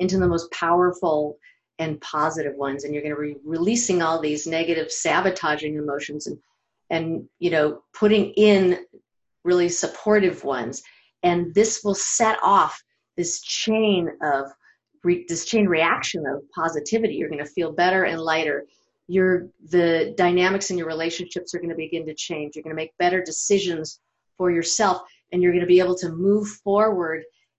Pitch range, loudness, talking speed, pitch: 160-185 Hz, -22 LUFS, 165 wpm, 175 Hz